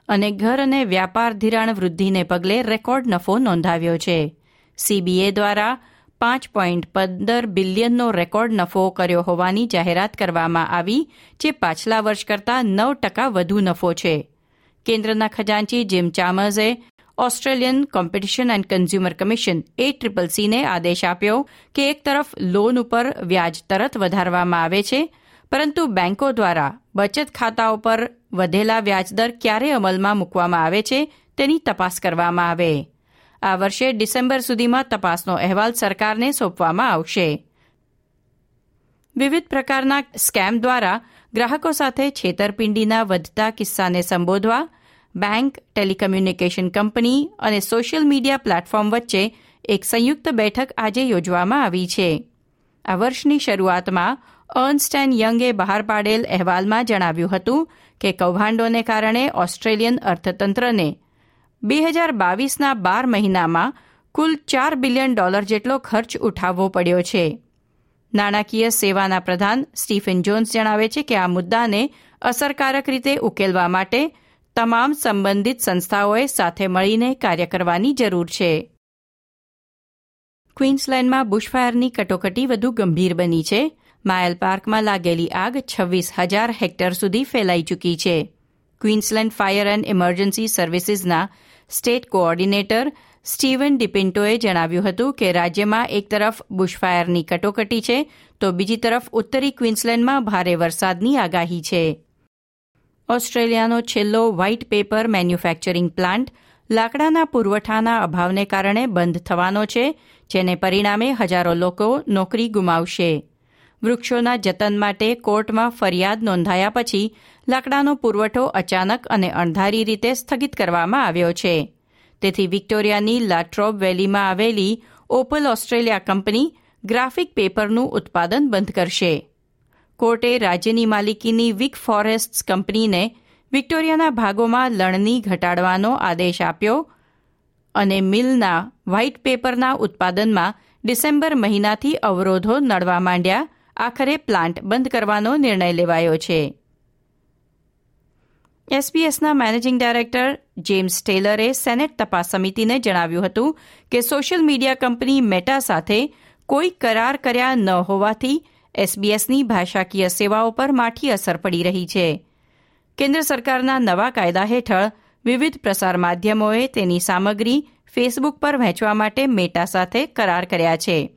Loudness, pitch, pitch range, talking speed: -19 LUFS, 215 Hz, 185-245 Hz, 115 wpm